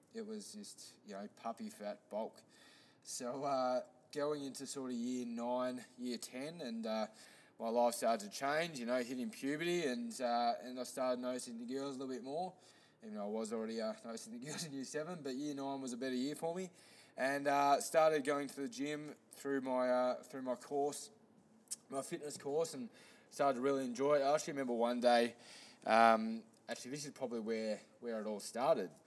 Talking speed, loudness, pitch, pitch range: 205 wpm, -39 LUFS, 130 Hz, 120-150 Hz